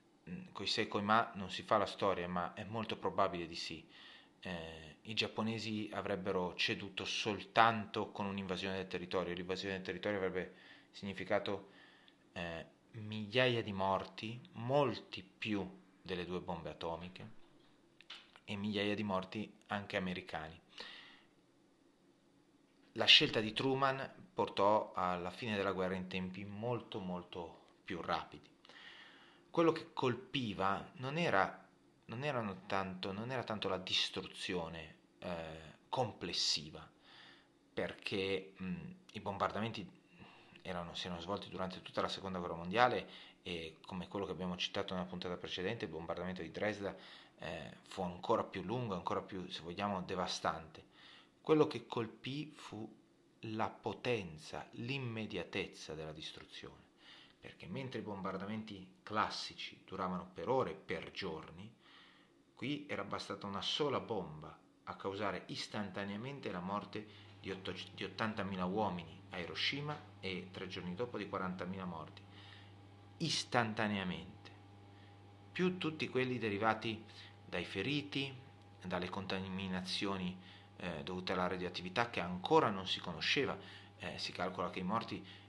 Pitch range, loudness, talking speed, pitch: 90-110 Hz, -39 LUFS, 125 wpm, 100 Hz